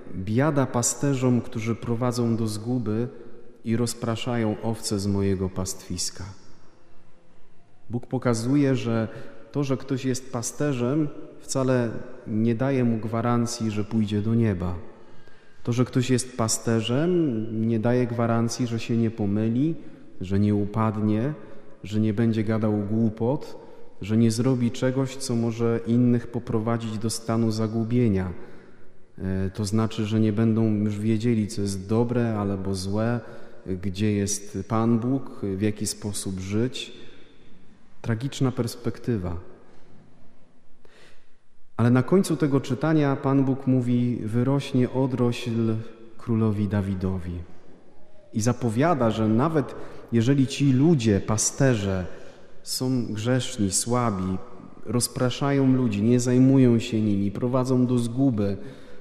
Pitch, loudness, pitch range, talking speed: 115 Hz, -25 LUFS, 110-125 Hz, 115 wpm